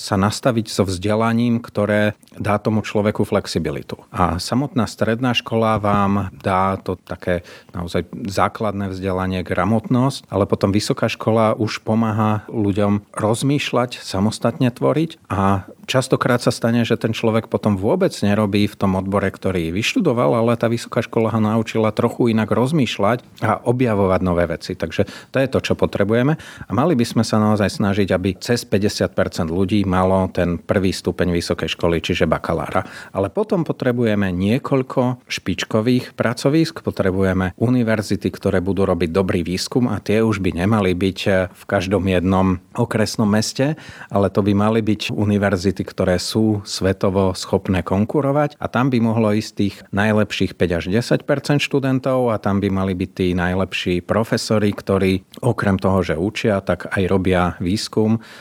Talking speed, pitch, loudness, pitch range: 150 wpm, 105 Hz, -19 LUFS, 95-115 Hz